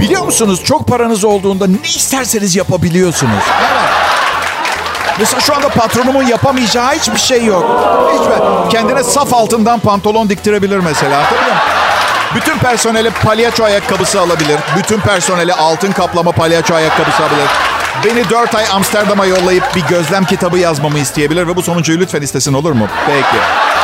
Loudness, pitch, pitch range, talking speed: -10 LUFS, 195 Hz, 170-225 Hz, 145 wpm